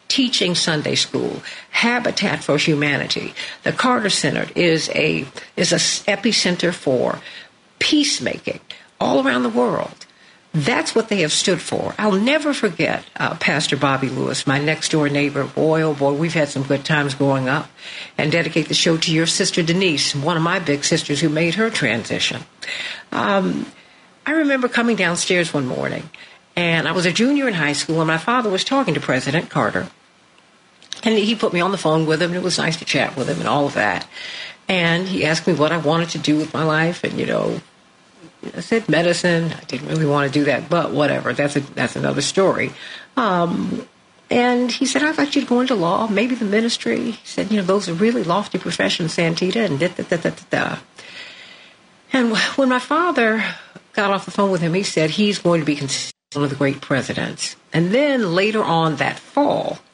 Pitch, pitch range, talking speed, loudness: 175 Hz, 155-225 Hz, 200 wpm, -19 LUFS